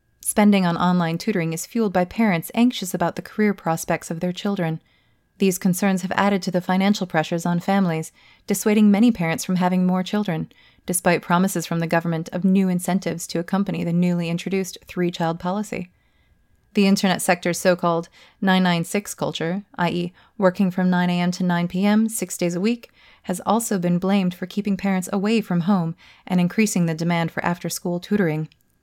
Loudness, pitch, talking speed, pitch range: -22 LUFS, 180 Hz, 180 wpm, 170-200 Hz